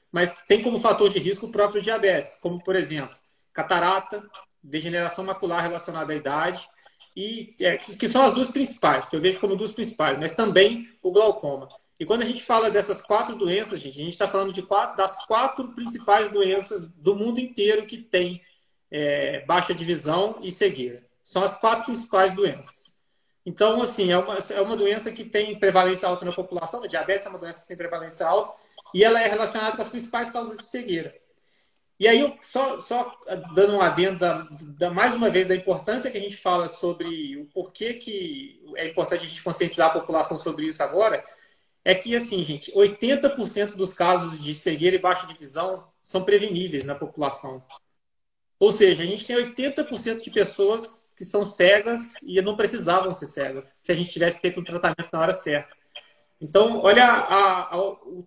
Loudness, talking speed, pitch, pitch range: -23 LUFS, 185 wpm, 195 Hz, 175-220 Hz